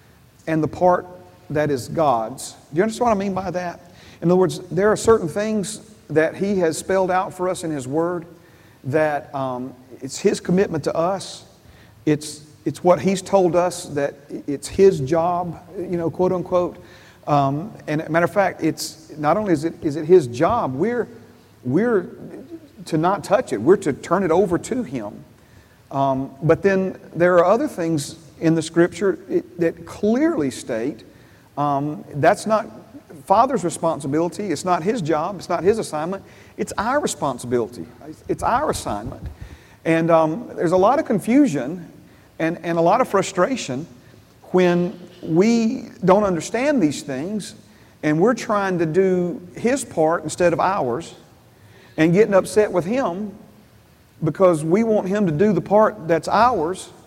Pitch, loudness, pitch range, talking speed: 175 Hz, -20 LUFS, 155-195 Hz, 165 wpm